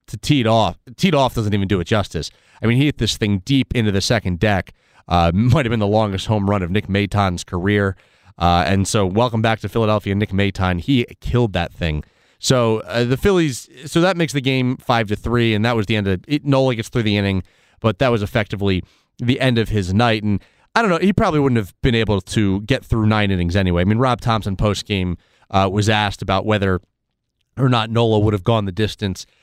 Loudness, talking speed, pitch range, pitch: -18 LUFS, 235 wpm, 100-120 Hz, 110 Hz